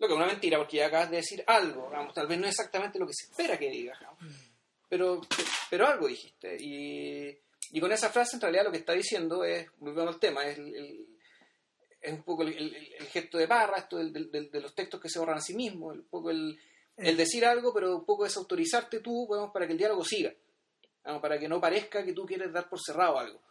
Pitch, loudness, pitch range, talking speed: 180 Hz, -31 LUFS, 155-240 Hz, 245 wpm